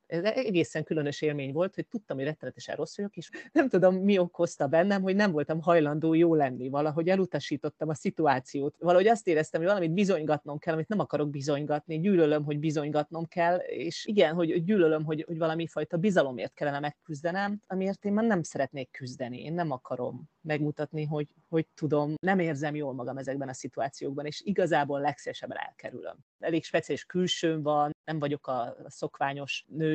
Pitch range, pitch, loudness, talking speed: 145-175 Hz, 155 Hz, -29 LUFS, 170 wpm